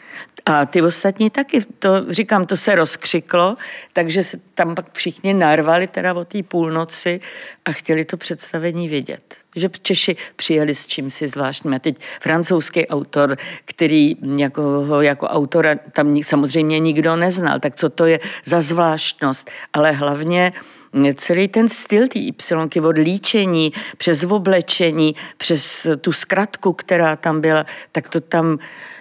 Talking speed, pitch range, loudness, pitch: 145 wpm, 155-185 Hz, -17 LUFS, 165 Hz